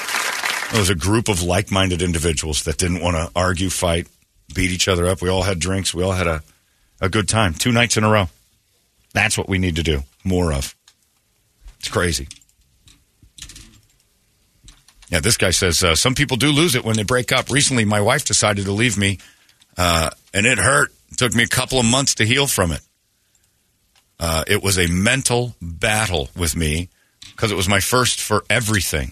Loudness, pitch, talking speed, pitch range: -18 LUFS, 95 Hz, 195 wpm, 85-110 Hz